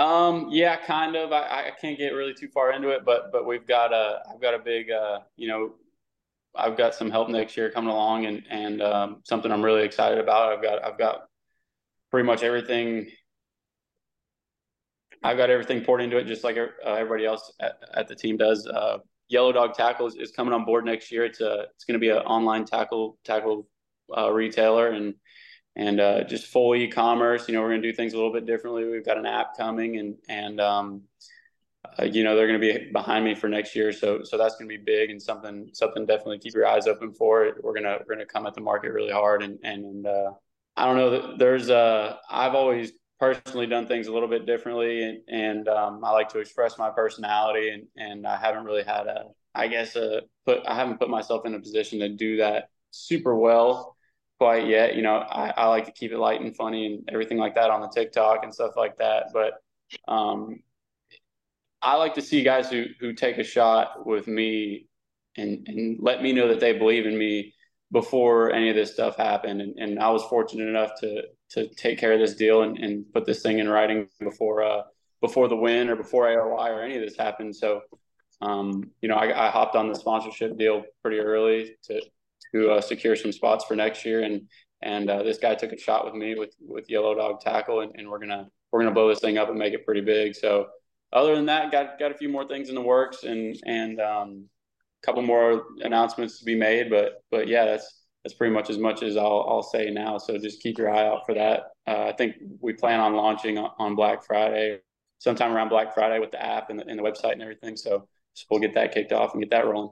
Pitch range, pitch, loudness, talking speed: 105-120 Hz, 110 Hz, -25 LUFS, 230 wpm